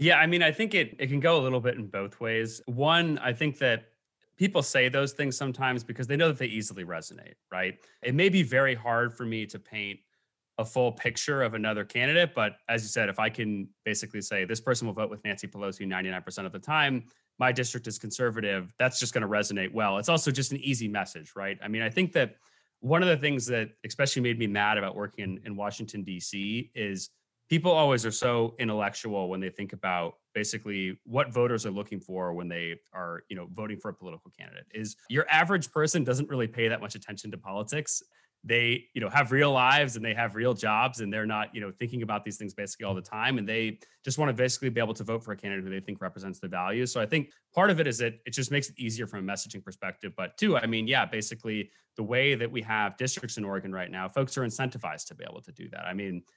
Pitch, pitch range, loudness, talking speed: 115 Hz, 100-130 Hz, -29 LUFS, 245 wpm